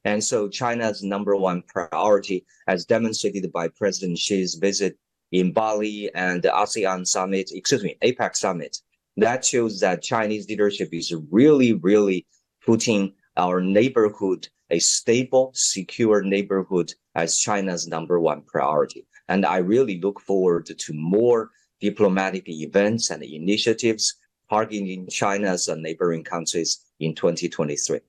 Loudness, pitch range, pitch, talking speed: -22 LUFS, 90-110 Hz, 100 Hz, 125 wpm